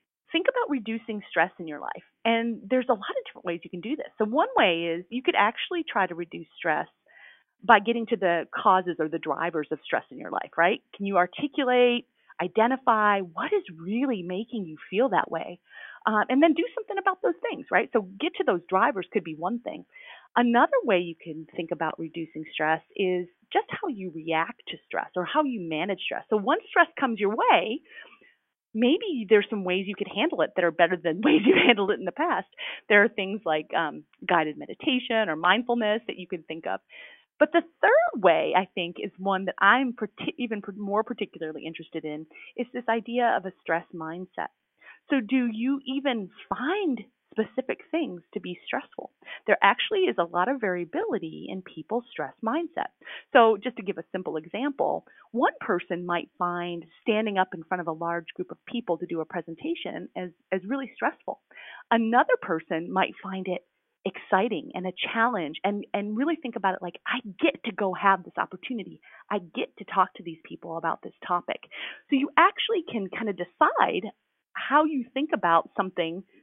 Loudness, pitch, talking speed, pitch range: -26 LUFS, 210 Hz, 195 wpm, 175-260 Hz